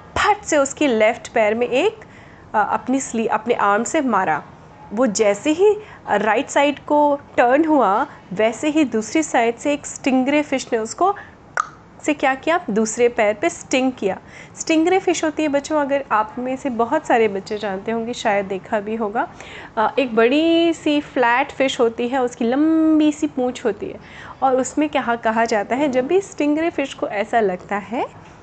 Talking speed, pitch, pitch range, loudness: 175 wpm, 260 Hz, 225-305 Hz, -19 LUFS